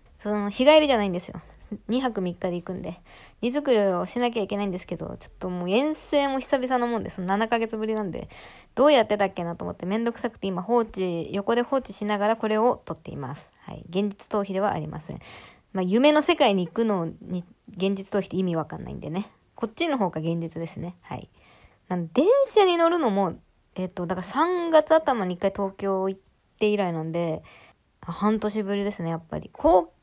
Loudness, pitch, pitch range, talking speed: -25 LUFS, 205 Hz, 185-240 Hz, 390 characters per minute